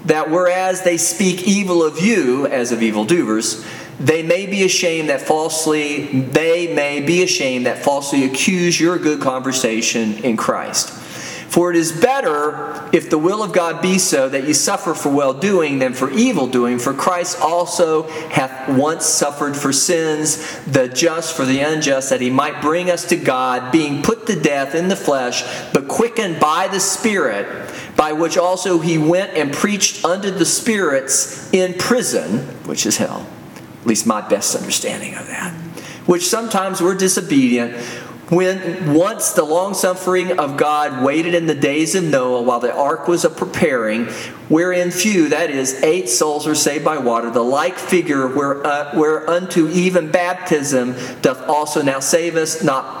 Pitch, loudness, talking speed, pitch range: 160 Hz, -17 LUFS, 170 wpm, 140-180 Hz